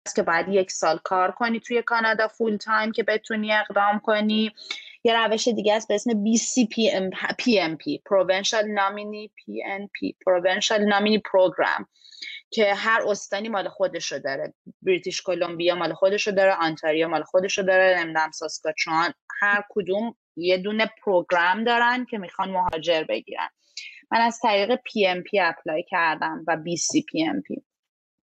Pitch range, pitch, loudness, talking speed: 185-225 Hz, 205 Hz, -23 LUFS, 145 wpm